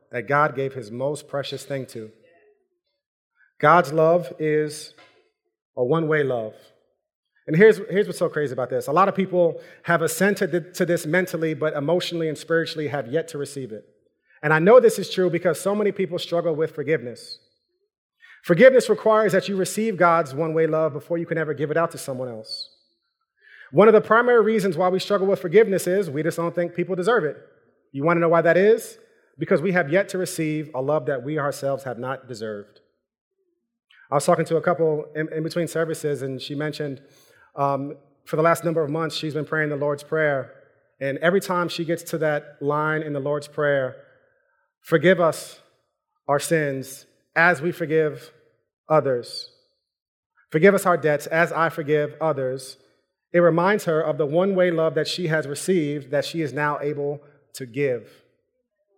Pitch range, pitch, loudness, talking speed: 145-185 Hz, 165 Hz, -22 LUFS, 185 wpm